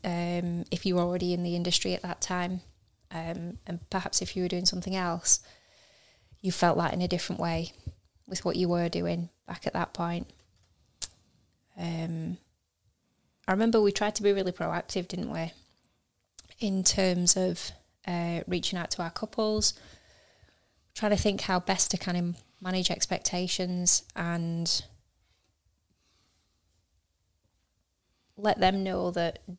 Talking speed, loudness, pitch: 145 wpm, -28 LUFS, 175 Hz